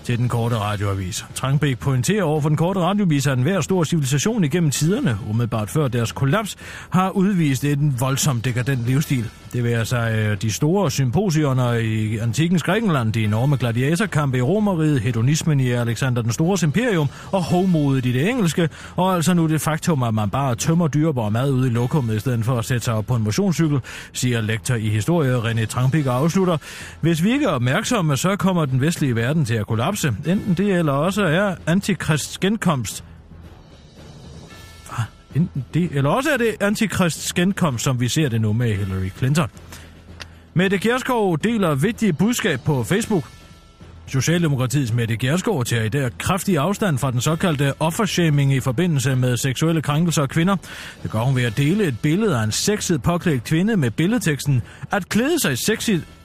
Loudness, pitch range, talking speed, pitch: -20 LUFS, 120-175 Hz, 175 wpm, 145 Hz